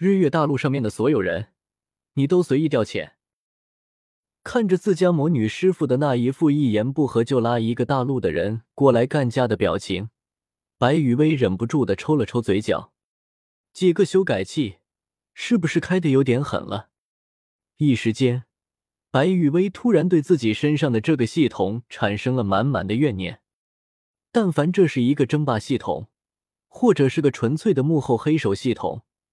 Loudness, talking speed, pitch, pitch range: -21 LUFS, 250 characters per minute, 130 Hz, 110-155 Hz